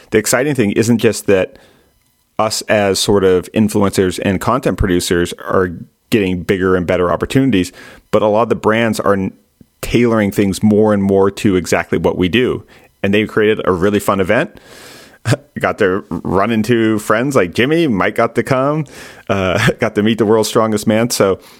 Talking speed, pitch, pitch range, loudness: 180 wpm, 105 Hz, 95-115 Hz, -14 LUFS